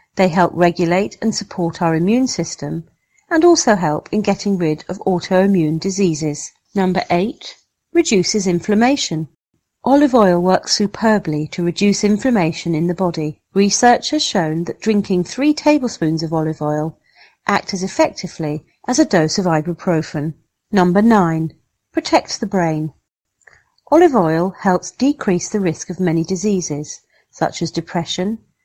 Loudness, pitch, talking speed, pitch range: -17 LUFS, 185 Hz, 140 wpm, 165-215 Hz